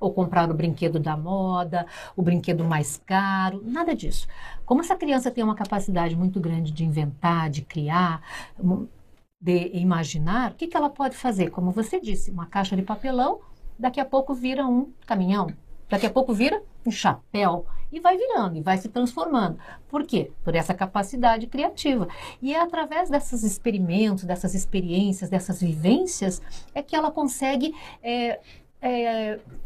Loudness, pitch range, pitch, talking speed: -25 LUFS, 180-260 Hz, 200 Hz, 160 wpm